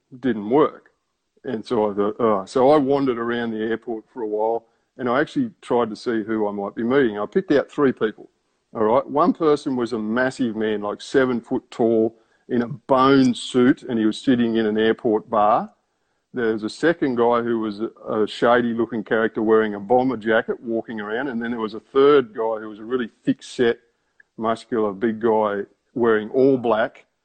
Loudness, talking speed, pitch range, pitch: -21 LUFS, 205 wpm, 110-125 Hz, 115 Hz